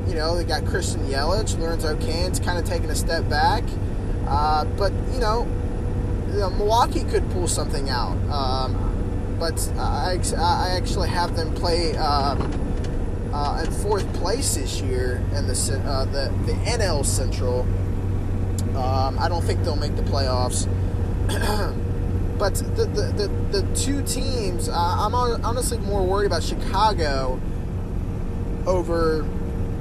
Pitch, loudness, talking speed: 95 Hz, -24 LUFS, 135 wpm